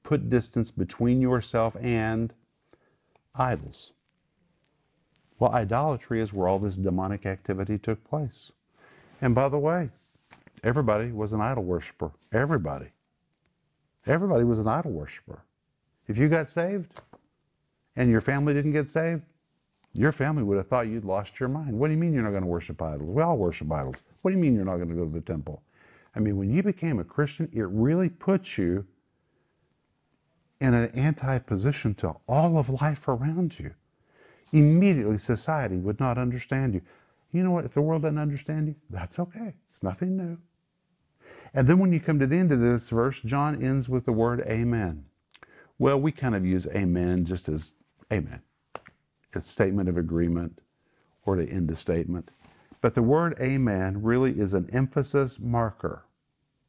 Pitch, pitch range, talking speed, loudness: 125 Hz, 100-150 Hz, 170 wpm, -26 LUFS